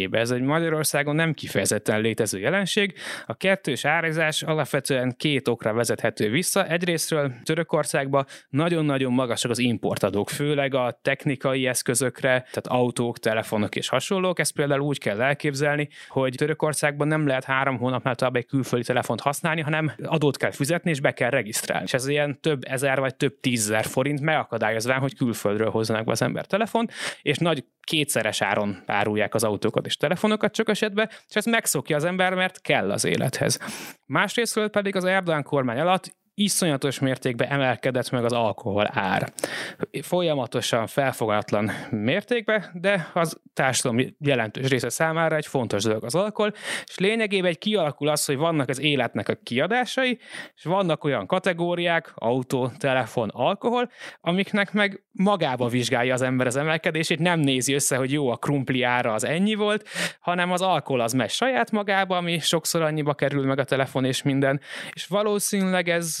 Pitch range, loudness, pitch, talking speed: 130-175 Hz, -24 LUFS, 145 Hz, 160 wpm